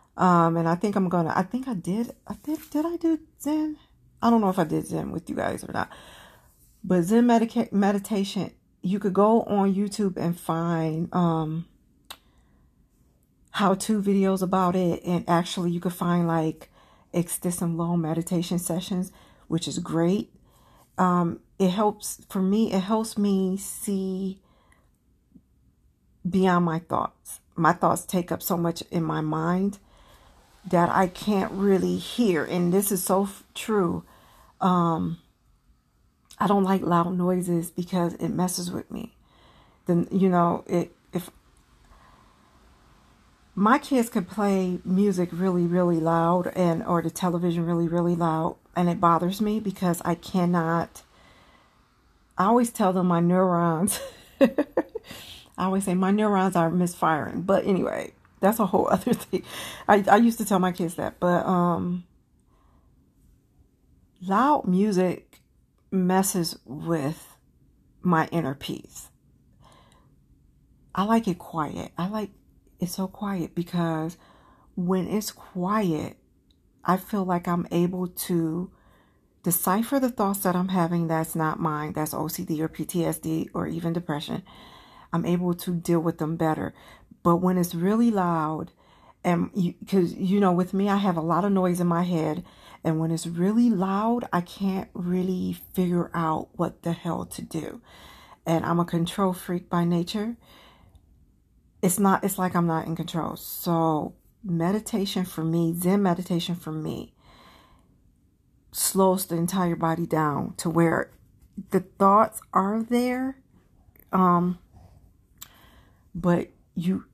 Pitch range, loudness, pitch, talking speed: 165-195 Hz, -25 LUFS, 180 Hz, 145 wpm